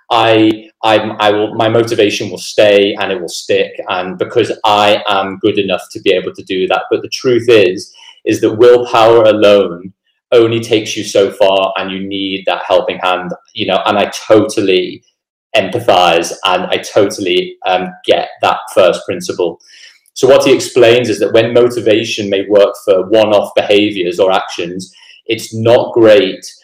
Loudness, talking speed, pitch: -11 LUFS, 170 wpm, 110 Hz